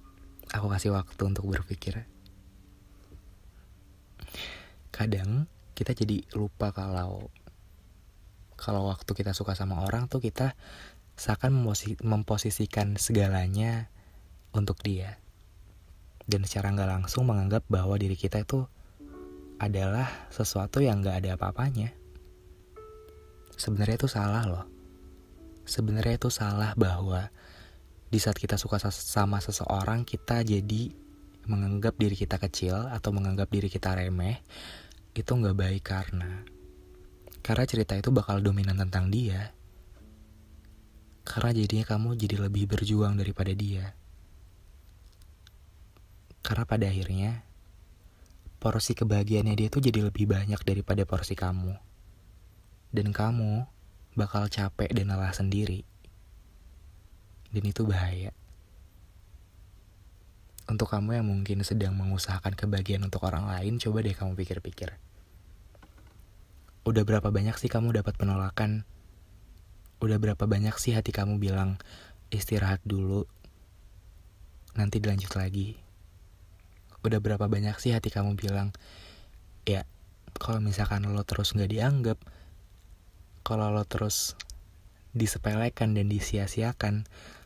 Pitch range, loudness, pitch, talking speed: 90-105 Hz, -30 LUFS, 100 Hz, 110 wpm